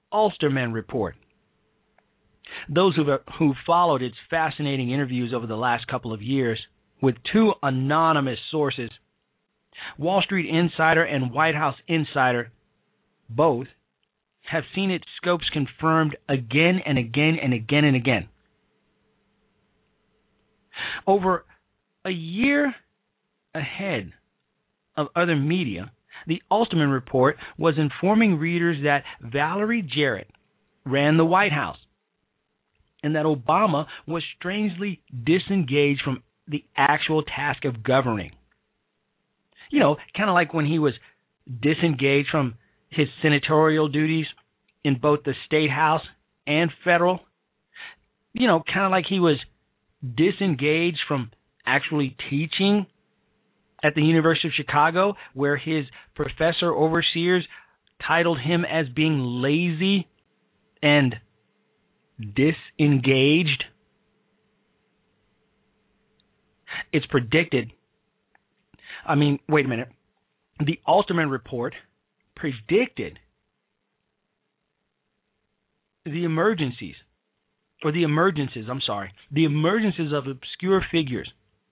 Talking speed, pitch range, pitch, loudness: 105 wpm, 135-175 Hz, 155 Hz, -23 LUFS